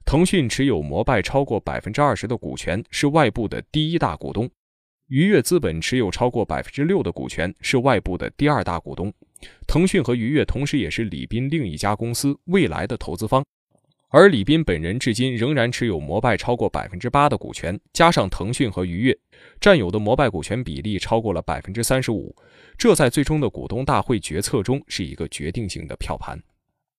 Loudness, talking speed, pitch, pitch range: -21 LUFS, 310 characters per minute, 120 Hz, 100-145 Hz